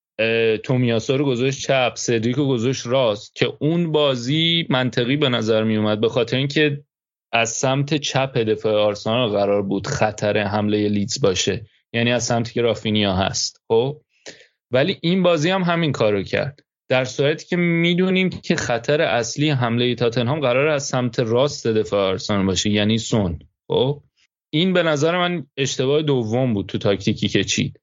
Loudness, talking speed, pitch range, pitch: -20 LUFS, 165 wpm, 110-145 Hz, 125 Hz